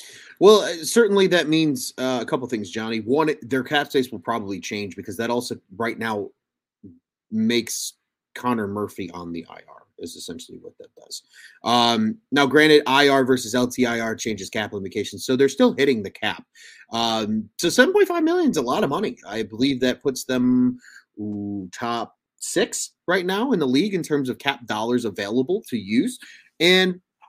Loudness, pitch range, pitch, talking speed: -21 LUFS, 110-155 Hz, 125 Hz, 170 wpm